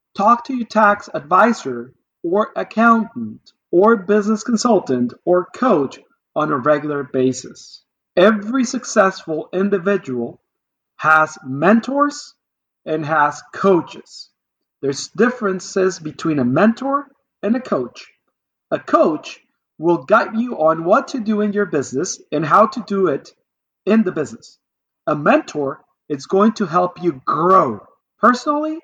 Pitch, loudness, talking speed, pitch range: 195 Hz, -17 LUFS, 125 wpm, 155-225 Hz